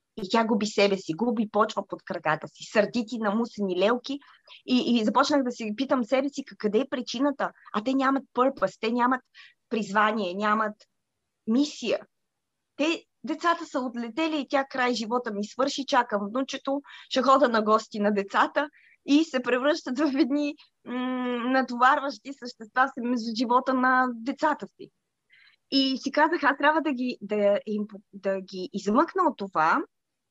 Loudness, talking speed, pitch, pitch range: -26 LUFS, 160 wpm, 250 Hz, 215-275 Hz